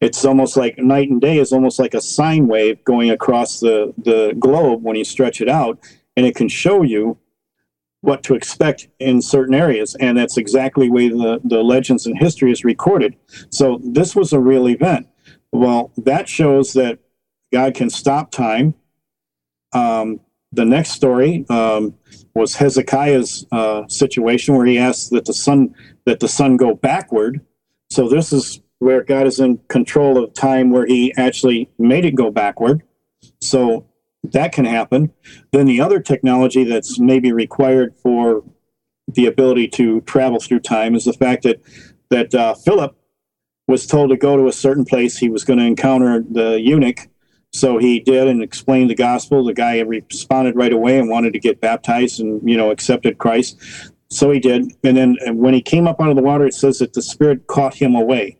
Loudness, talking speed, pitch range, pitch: -15 LUFS, 185 wpm, 115-135 Hz, 125 Hz